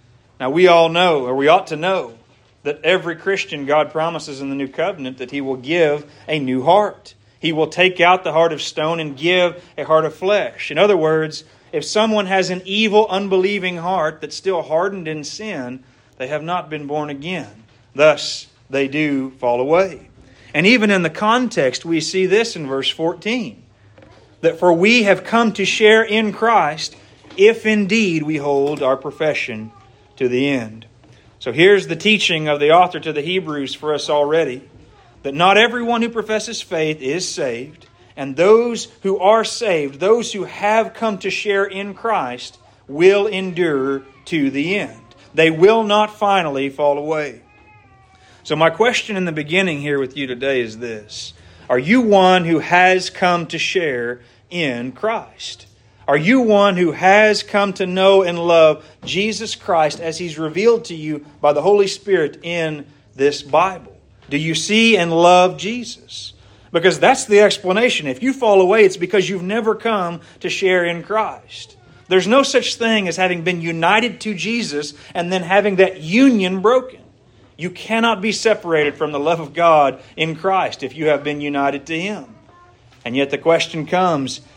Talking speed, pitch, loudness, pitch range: 175 wpm, 165 Hz, -17 LUFS, 140-195 Hz